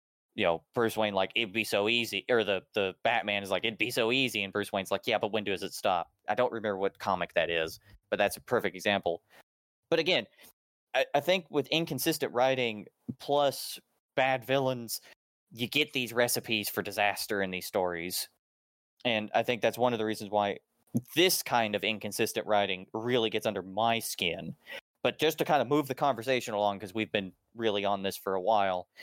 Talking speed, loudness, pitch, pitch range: 205 wpm, -30 LUFS, 110 Hz, 100-125 Hz